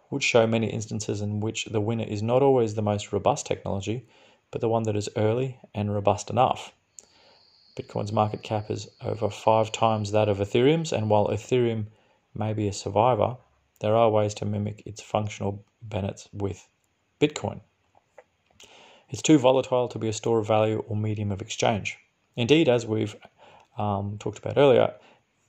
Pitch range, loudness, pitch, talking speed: 105-115 Hz, -25 LUFS, 110 Hz, 165 wpm